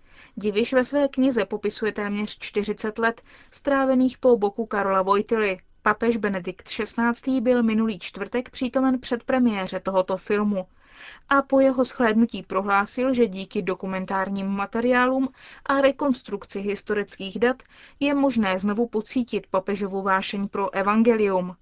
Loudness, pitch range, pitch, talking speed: -24 LUFS, 200-250 Hz, 215 Hz, 125 wpm